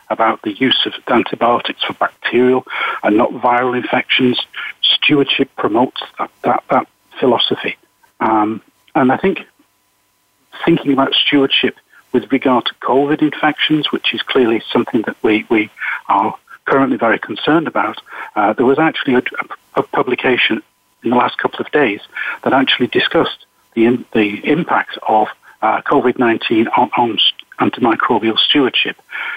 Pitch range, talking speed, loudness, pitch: 120-140 Hz, 140 wpm, -15 LUFS, 125 Hz